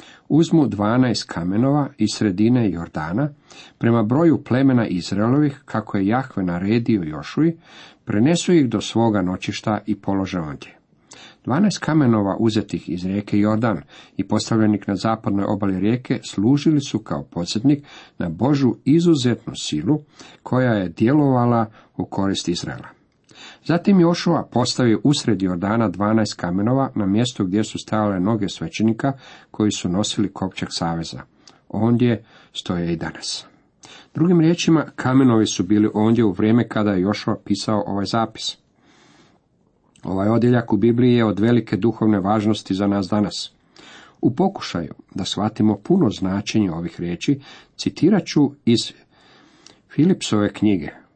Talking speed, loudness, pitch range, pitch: 130 wpm, -20 LUFS, 100-135 Hz, 110 Hz